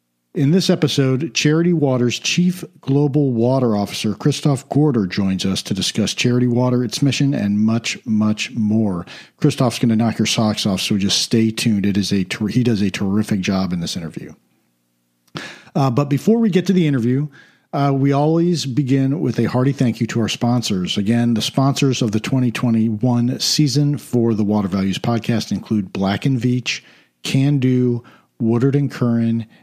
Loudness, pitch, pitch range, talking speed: -18 LUFS, 120 Hz, 110-140 Hz, 175 wpm